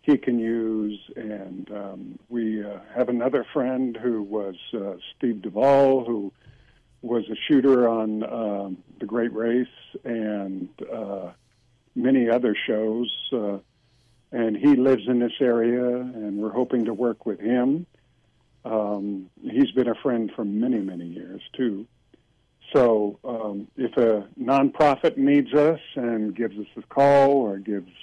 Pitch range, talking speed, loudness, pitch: 105-130 Hz, 145 wpm, -24 LUFS, 120 Hz